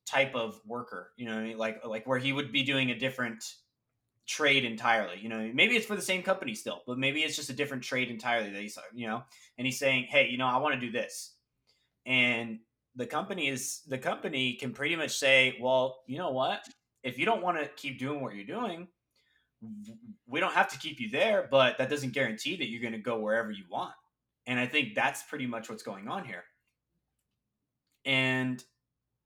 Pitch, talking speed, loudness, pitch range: 130 Hz, 210 wpm, -30 LUFS, 120-145 Hz